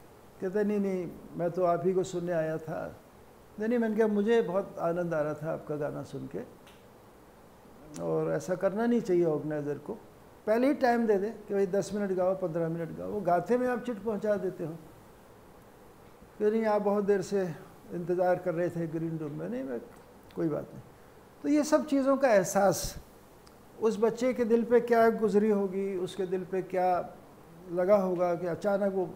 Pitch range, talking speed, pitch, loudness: 175-215 Hz, 190 wpm, 190 Hz, -30 LUFS